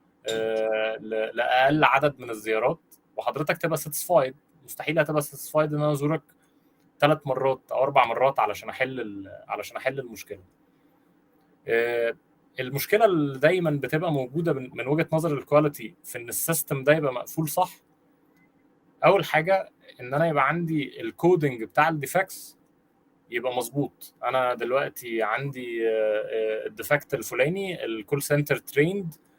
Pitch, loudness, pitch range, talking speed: 145 Hz, -25 LUFS, 125-155 Hz, 120 wpm